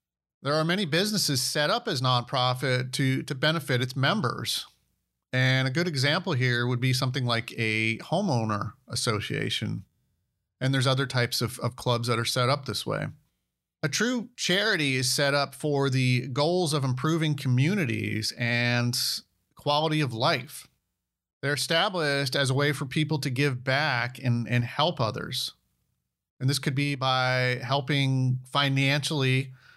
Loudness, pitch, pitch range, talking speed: -26 LUFS, 130 Hz, 125-145 Hz, 150 wpm